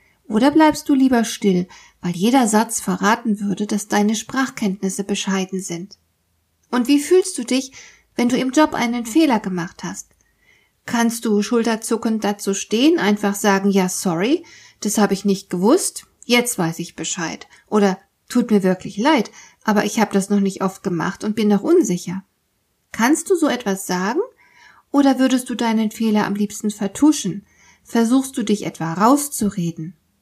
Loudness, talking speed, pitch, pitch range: -19 LUFS, 160 wpm, 210 Hz, 195-250 Hz